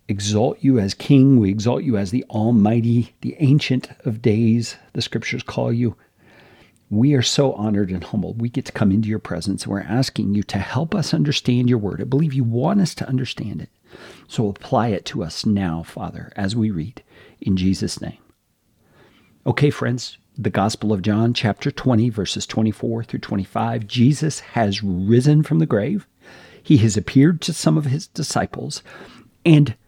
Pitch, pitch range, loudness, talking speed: 115 Hz, 105-135 Hz, -20 LUFS, 175 wpm